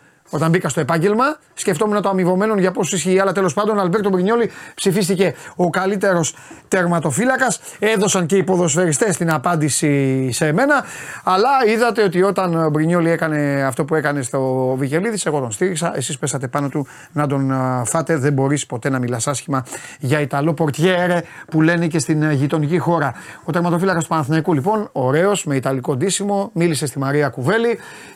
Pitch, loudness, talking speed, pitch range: 165 Hz, -18 LUFS, 165 wpm, 145-190 Hz